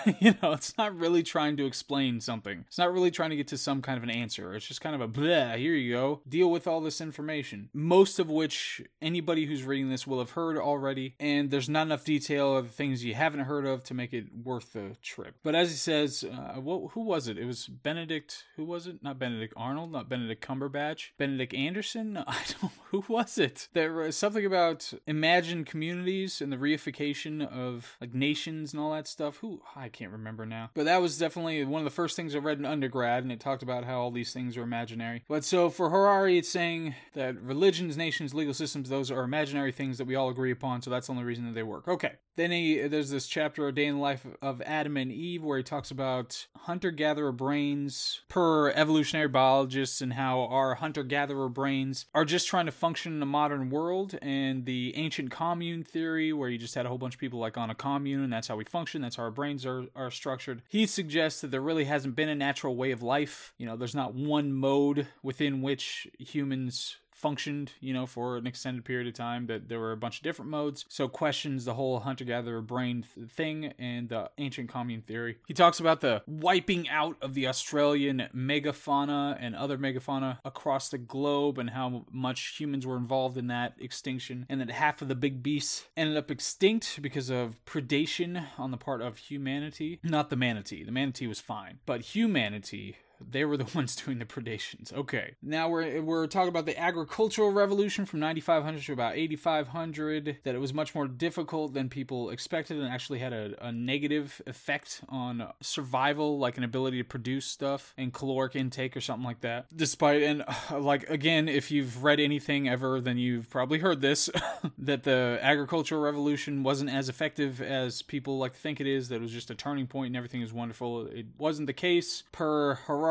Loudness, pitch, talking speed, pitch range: -31 LUFS, 140 Hz, 210 wpm, 130-155 Hz